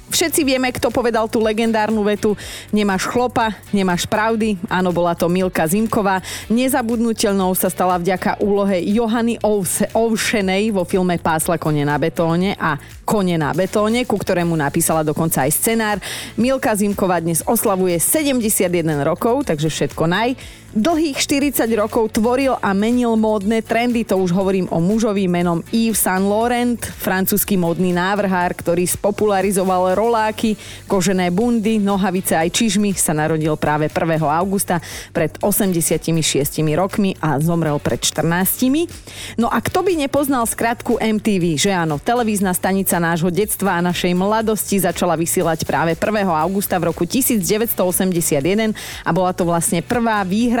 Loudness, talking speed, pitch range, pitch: -18 LUFS, 140 wpm, 175-220 Hz, 195 Hz